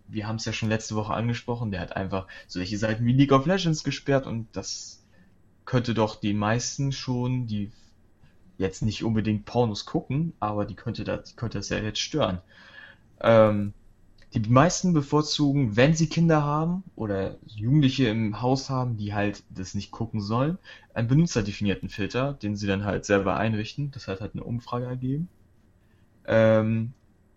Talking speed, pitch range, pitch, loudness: 165 wpm, 105-130 Hz, 110 Hz, -26 LUFS